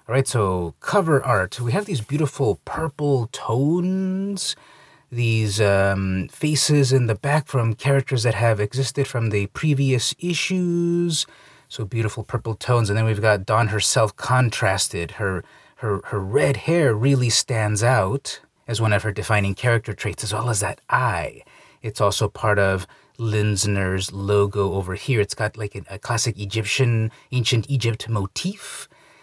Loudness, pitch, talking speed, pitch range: -21 LUFS, 115 Hz, 150 wpm, 105-140 Hz